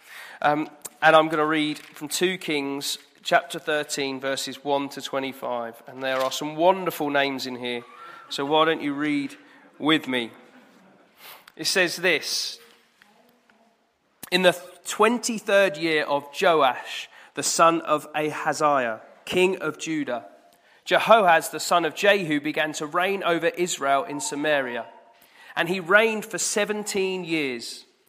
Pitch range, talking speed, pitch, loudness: 145-190 Hz, 135 wpm, 160 Hz, -23 LUFS